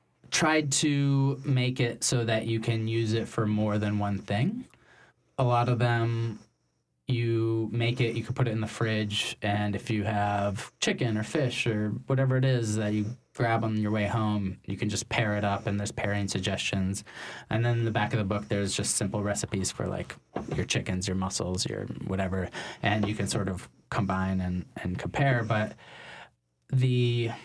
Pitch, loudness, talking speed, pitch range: 110 Hz, -29 LUFS, 190 wpm, 100-120 Hz